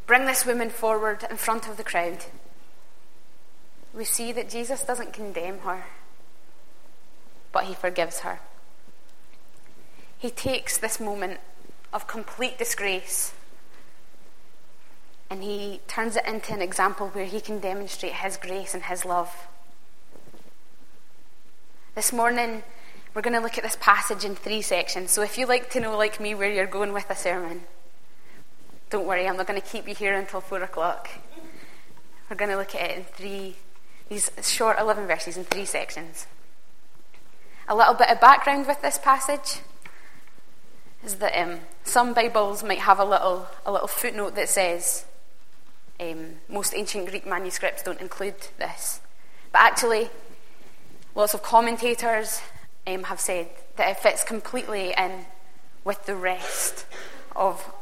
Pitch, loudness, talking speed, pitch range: 205 Hz, -25 LUFS, 150 wpm, 185-230 Hz